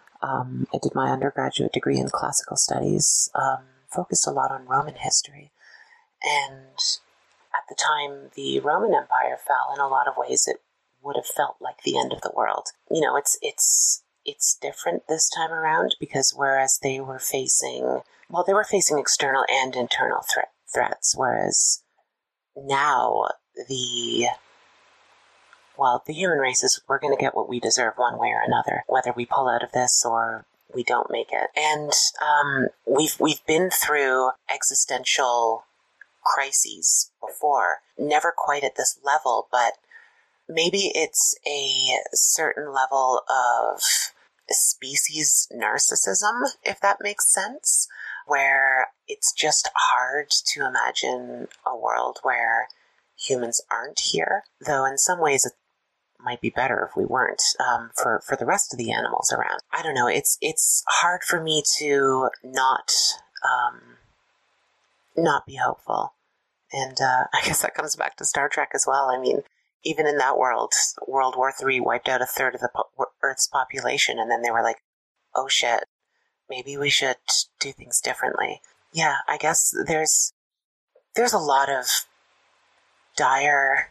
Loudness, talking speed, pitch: -22 LUFS, 155 wpm, 150 Hz